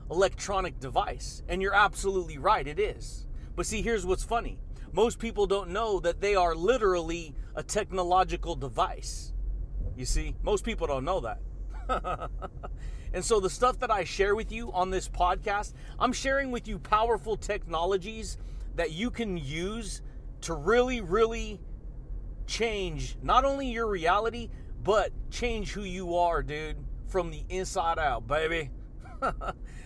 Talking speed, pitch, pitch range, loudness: 145 wpm, 195 Hz, 170-225 Hz, -30 LUFS